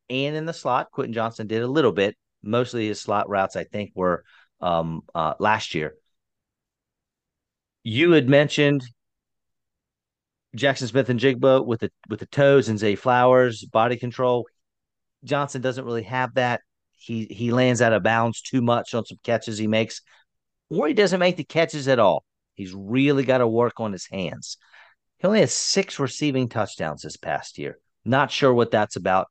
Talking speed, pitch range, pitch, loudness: 175 wpm, 110-135 Hz, 125 Hz, -22 LUFS